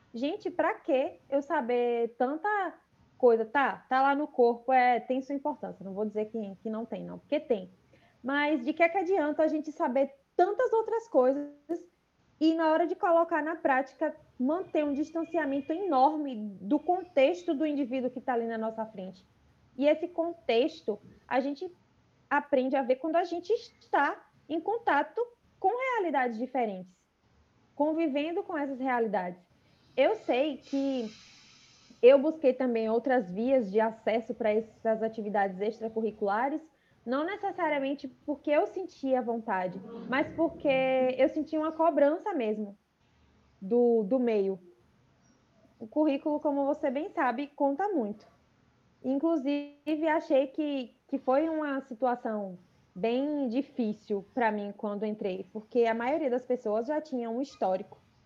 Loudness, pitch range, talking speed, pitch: -30 LUFS, 230-310 Hz, 145 wpm, 275 Hz